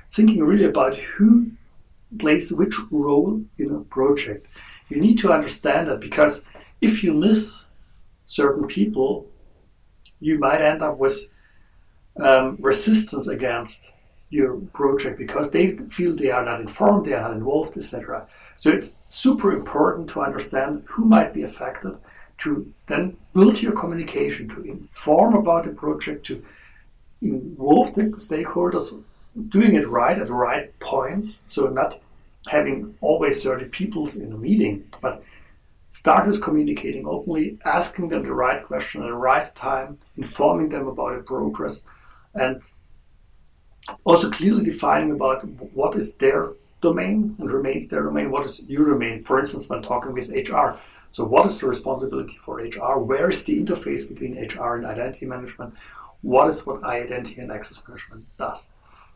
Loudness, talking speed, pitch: -21 LUFS, 150 wpm, 145 Hz